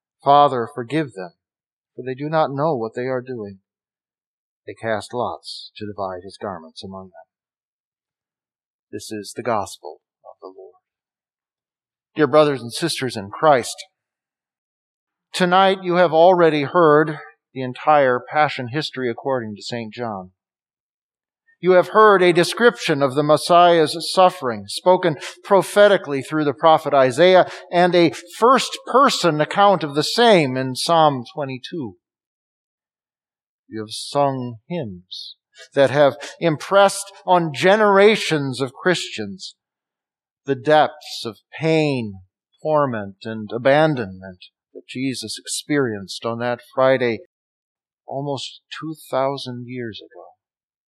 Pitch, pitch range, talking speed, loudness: 145 Hz, 120-175 Hz, 120 wpm, -18 LUFS